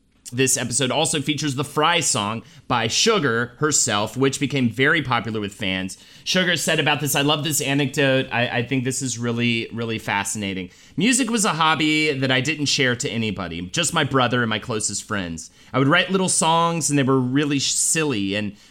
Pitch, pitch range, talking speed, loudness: 135 Hz, 115-150 Hz, 195 wpm, -20 LUFS